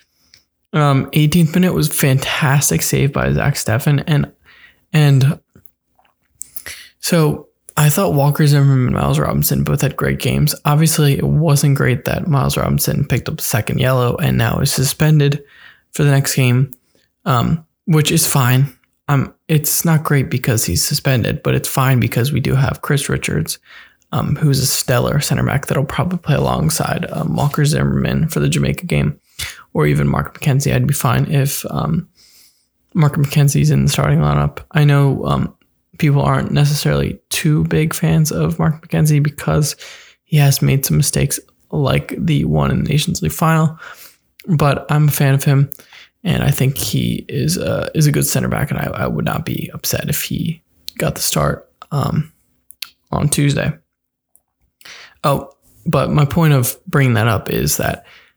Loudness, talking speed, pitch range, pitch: -16 LUFS, 170 wpm, 130-155 Hz, 145 Hz